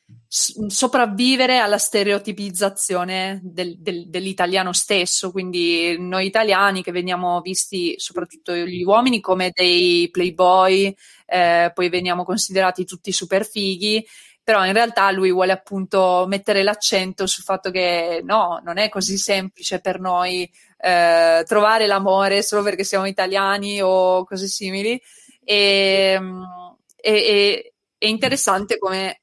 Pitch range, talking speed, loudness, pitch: 180-205 Hz, 125 wpm, -18 LUFS, 190 Hz